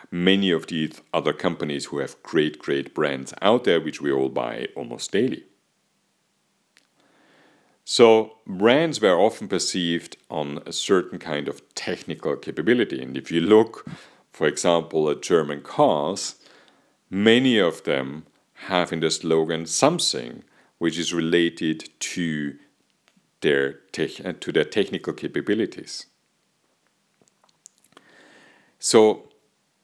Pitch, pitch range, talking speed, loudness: 85 Hz, 75-90 Hz, 115 wpm, -23 LUFS